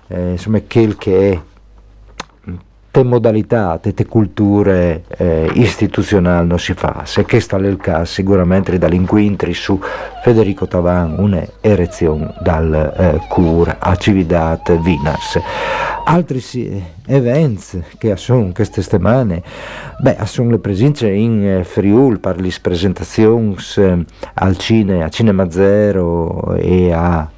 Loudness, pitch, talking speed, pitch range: -14 LUFS, 95 Hz, 120 wpm, 90-110 Hz